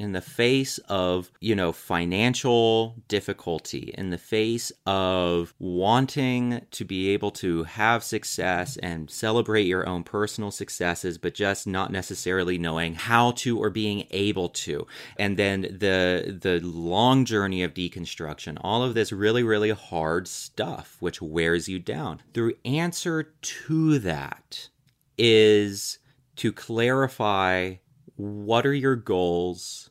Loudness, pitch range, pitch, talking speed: -25 LUFS, 90-115 Hz, 100 Hz, 130 wpm